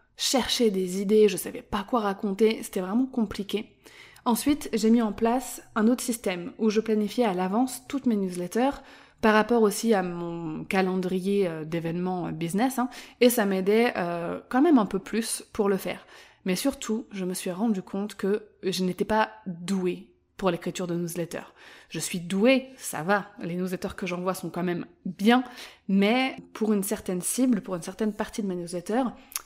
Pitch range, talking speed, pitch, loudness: 185-235 Hz, 180 wpm, 210 Hz, -27 LUFS